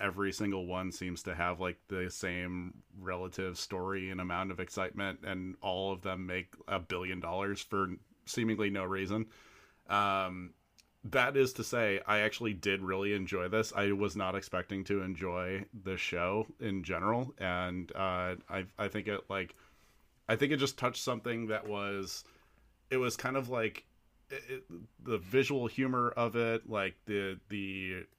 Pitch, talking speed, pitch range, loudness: 100 Hz, 165 wpm, 95-110 Hz, -35 LUFS